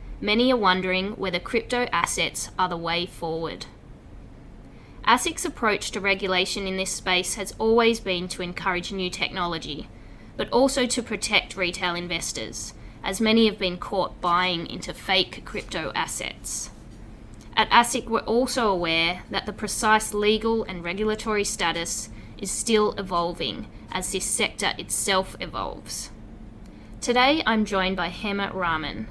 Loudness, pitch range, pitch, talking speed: -24 LUFS, 175-220 Hz, 190 Hz, 135 wpm